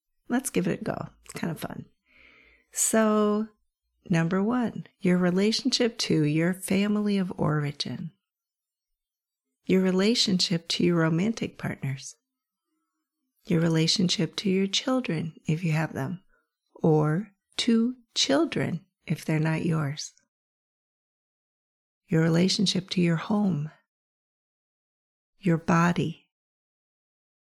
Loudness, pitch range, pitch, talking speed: -26 LUFS, 160-215 Hz, 185 Hz, 105 wpm